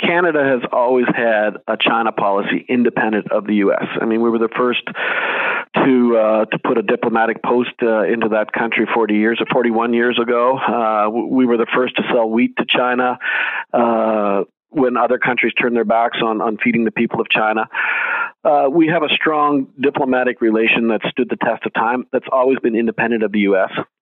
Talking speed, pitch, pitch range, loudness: 195 wpm, 115 Hz, 110-125 Hz, -16 LUFS